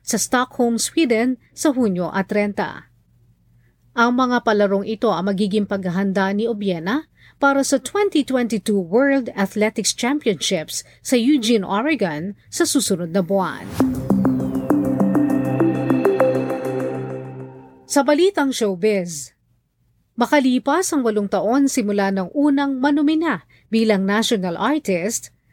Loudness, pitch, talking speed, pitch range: -19 LUFS, 210 Hz, 100 wpm, 180-255 Hz